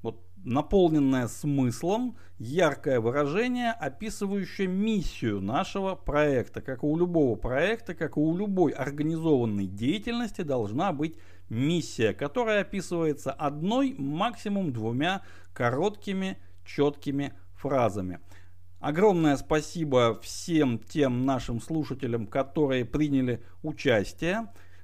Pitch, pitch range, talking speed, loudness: 145 Hz, 120-180 Hz, 95 wpm, -28 LUFS